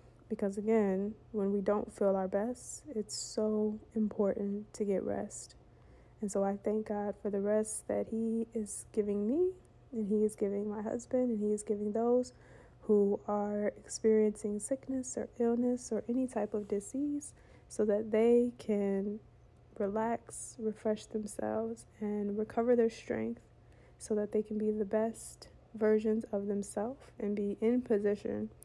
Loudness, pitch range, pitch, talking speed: -34 LUFS, 205-225 Hz, 215 Hz, 155 wpm